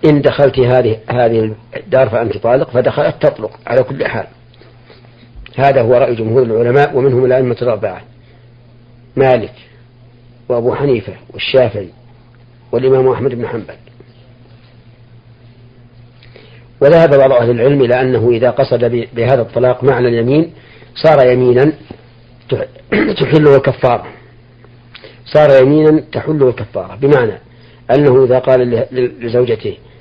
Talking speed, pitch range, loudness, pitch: 105 wpm, 120-130 Hz, -12 LUFS, 120 Hz